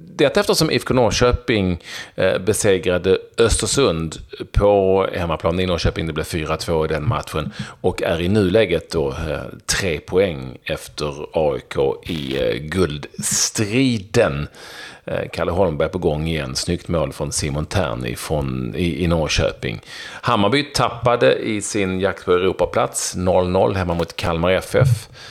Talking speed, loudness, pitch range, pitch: 135 wpm, -19 LUFS, 85-120 Hz, 95 Hz